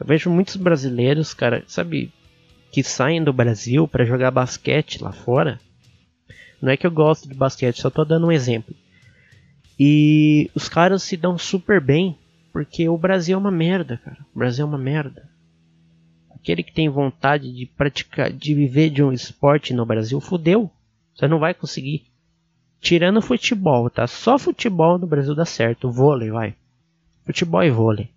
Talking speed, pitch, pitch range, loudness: 175 wpm, 145 Hz, 125-165 Hz, -19 LUFS